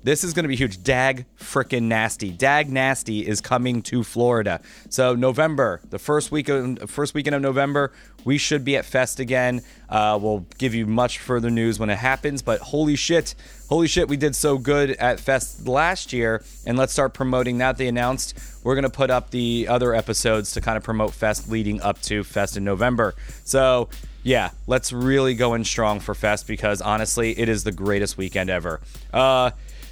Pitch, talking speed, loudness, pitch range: 125 Hz, 200 wpm, -22 LUFS, 110-135 Hz